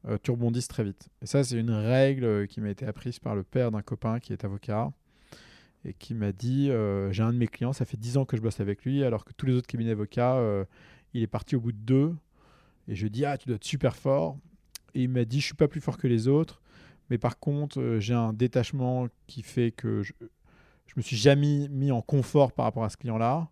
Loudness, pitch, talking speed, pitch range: -28 LUFS, 120 Hz, 260 wpm, 110-135 Hz